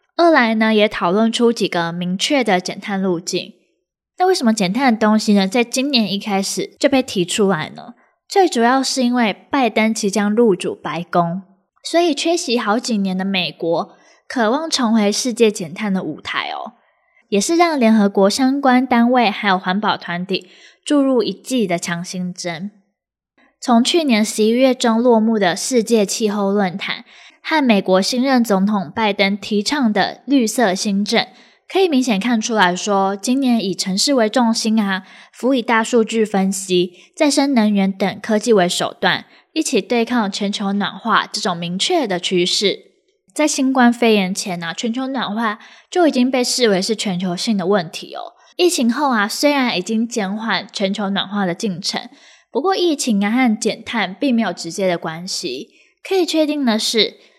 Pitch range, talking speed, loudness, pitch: 195-255 Hz, 255 characters per minute, -17 LUFS, 220 Hz